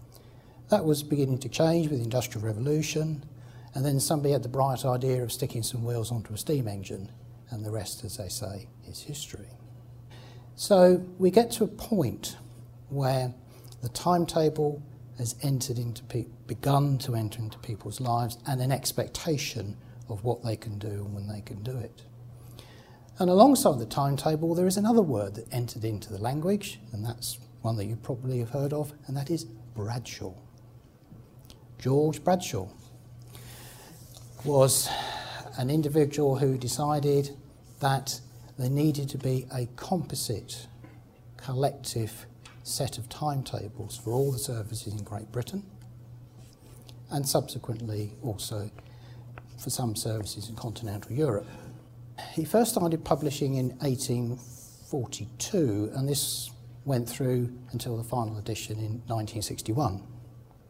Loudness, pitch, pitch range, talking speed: -29 LUFS, 120 Hz, 115-140 Hz, 140 wpm